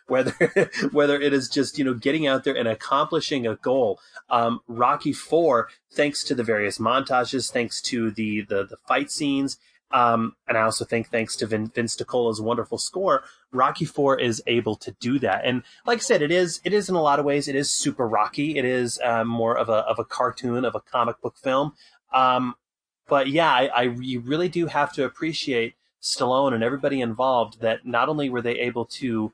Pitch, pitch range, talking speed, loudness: 125 Hz, 115-145 Hz, 205 wpm, -23 LUFS